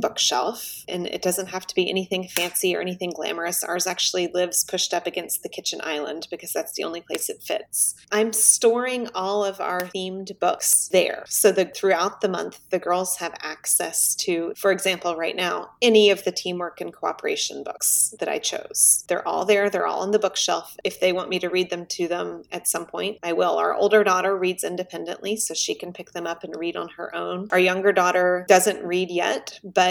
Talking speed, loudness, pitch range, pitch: 210 wpm, -22 LUFS, 180-200 Hz, 185 Hz